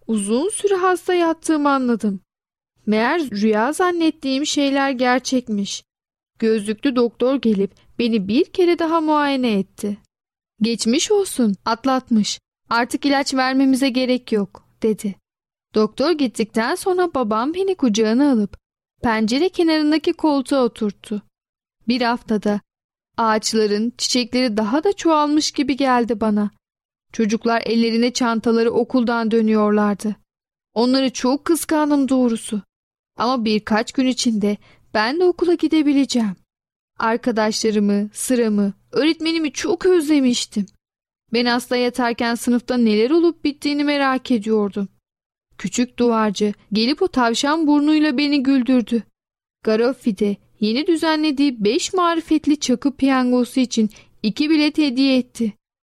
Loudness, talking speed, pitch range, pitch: -19 LUFS, 110 wpm, 220-295 Hz, 250 Hz